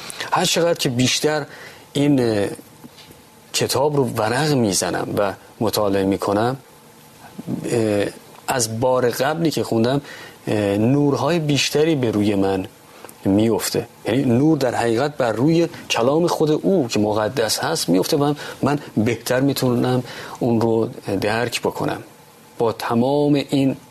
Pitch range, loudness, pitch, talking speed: 115-145 Hz, -20 LUFS, 125 Hz, 120 wpm